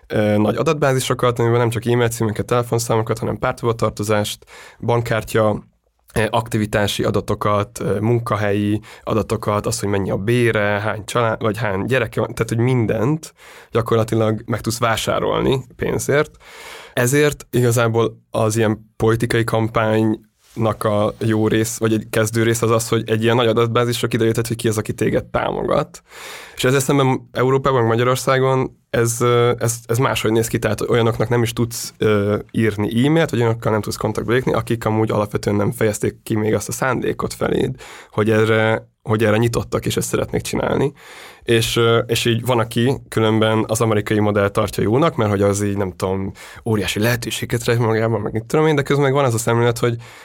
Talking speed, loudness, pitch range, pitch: 165 wpm, -19 LUFS, 110-120 Hz, 115 Hz